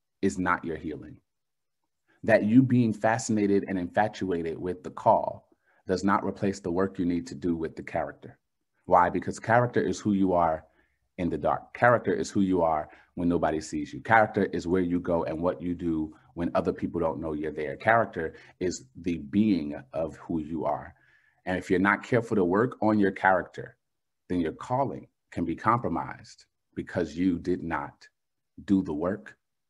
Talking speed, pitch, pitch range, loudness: 185 wpm, 90 Hz, 85-100 Hz, -27 LUFS